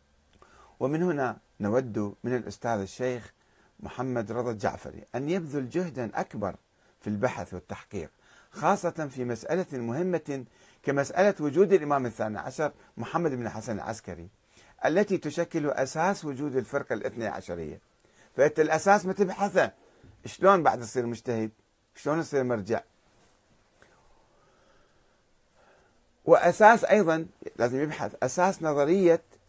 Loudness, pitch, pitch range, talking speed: -27 LUFS, 135 Hz, 115-165 Hz, 110 wpm